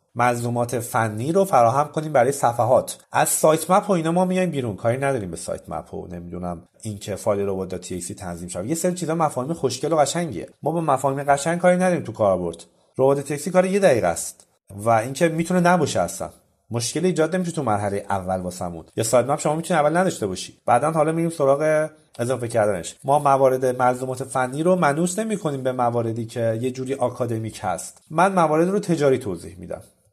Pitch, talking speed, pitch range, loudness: 135 Hz, 190 wpm, 115-165 Hz, -22 LUFS